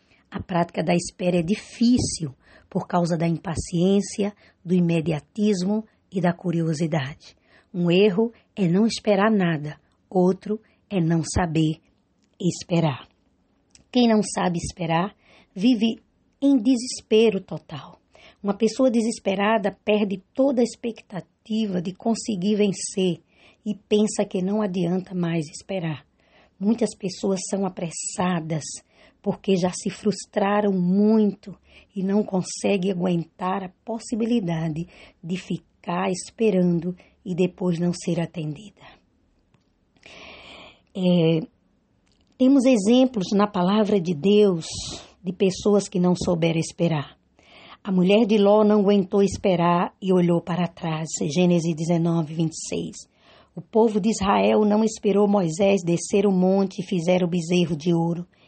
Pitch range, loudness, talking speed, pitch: 175-210 Hz, -23 LUFS, 120 wpm, 190 Hz